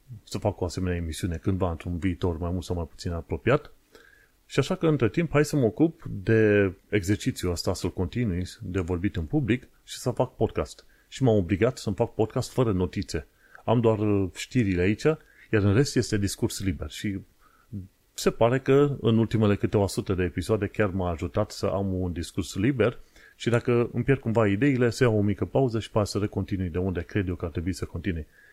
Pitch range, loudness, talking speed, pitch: 95-120 Hz, -26 LUFS, 200 wpm, 105 Hz